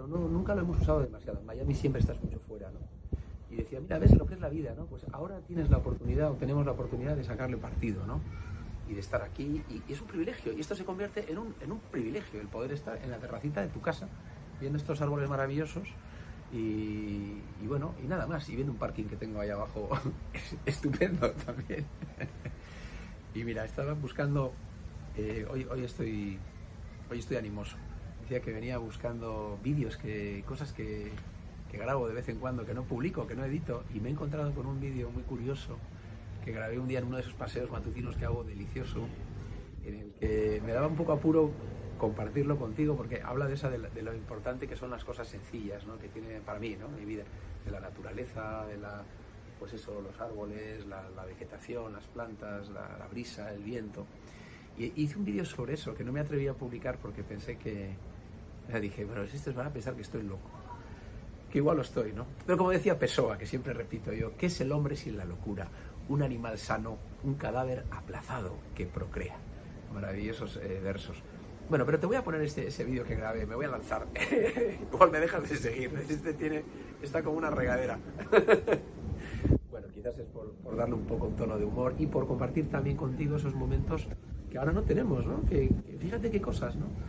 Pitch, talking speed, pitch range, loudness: 115 Hz, 205 wpm, 105-135 Hz, -35 LUFS